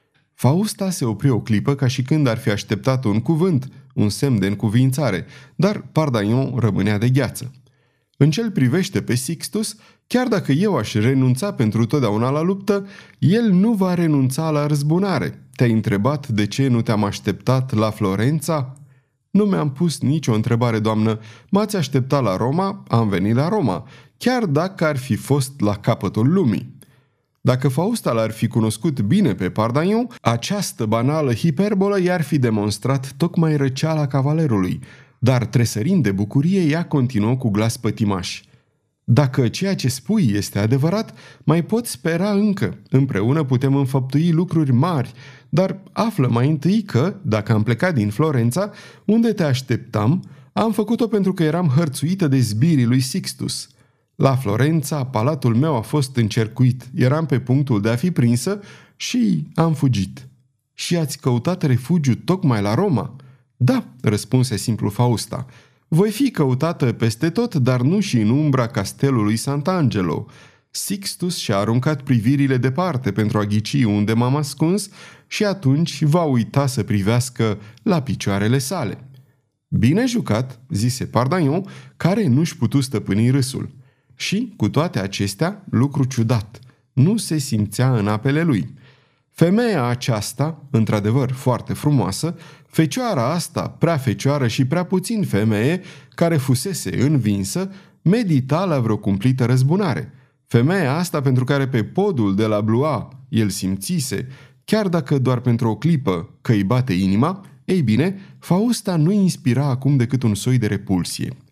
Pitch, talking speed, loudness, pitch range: 135 Hz, 145 wpm, -19 LUFS, 115-165 Hz